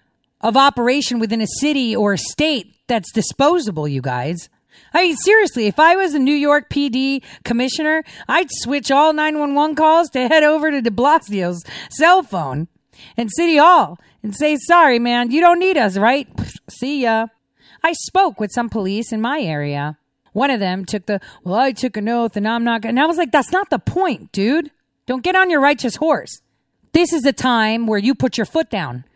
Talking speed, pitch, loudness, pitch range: 200 wpm, 255 Hz, -16 LUFS, 215-310 Hz